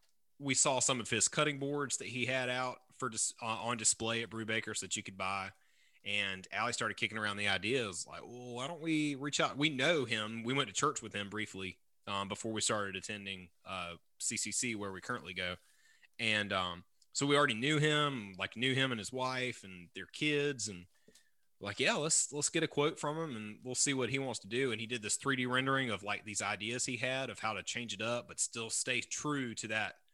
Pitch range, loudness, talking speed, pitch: 105-130 Hz, -35 LUFS, 235 wpm, 115 Hz